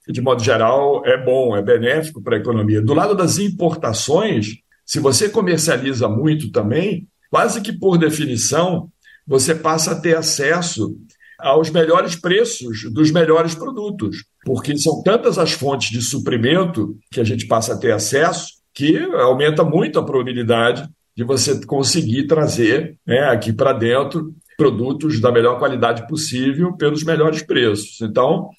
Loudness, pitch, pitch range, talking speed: -17 LUFS, 155 Hz, 130-170 Hz, 145 wpm